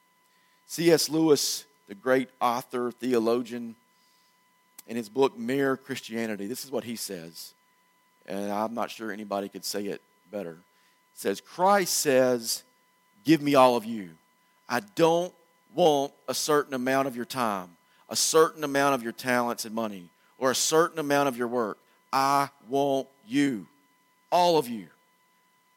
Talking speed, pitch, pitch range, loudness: 150 wpm, 135 Hz, 120-165 Hz, -26 LUFS